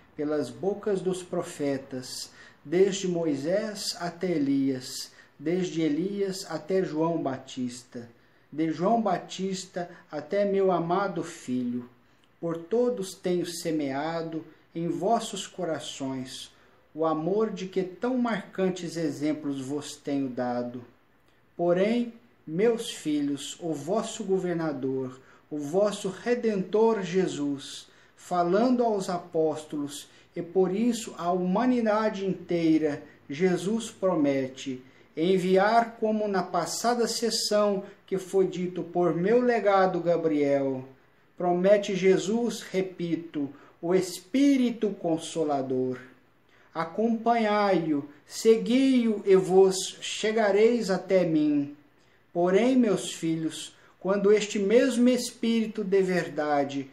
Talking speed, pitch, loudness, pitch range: 100 wpm, 175 Hz, -27 LUFS, 150-205 Hz